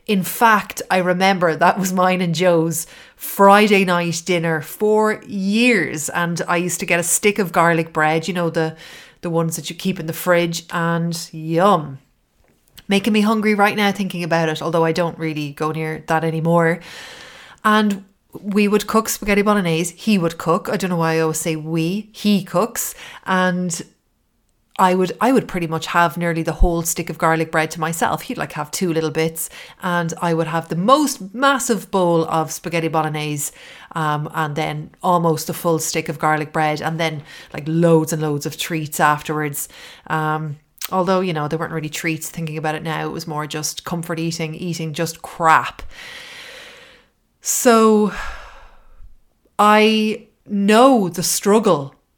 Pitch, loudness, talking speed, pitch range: 170 Hz, -18 LUFS, 175 wpm, 160-200 Hz